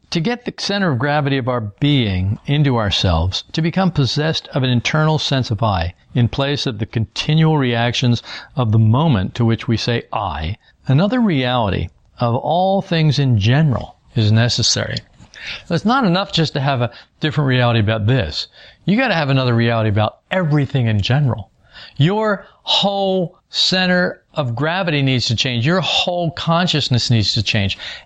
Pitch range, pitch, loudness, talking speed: 115-165 Hz, 135 Hz, -17 LUFS, 165 wpm